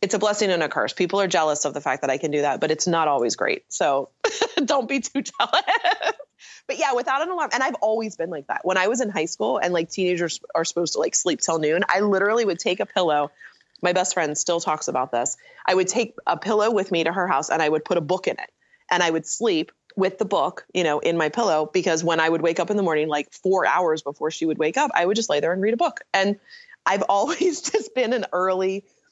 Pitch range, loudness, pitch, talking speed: 160-215 Hz, -22 LUFS, 180 Hz, 270 wpm